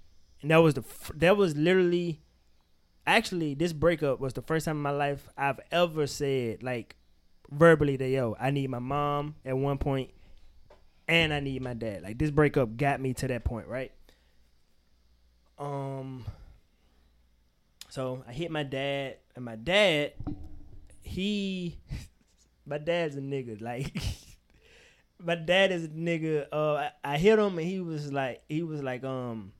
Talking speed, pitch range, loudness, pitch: 160 wpm, 110-160 Hz, -29 LUFS, 140 Hz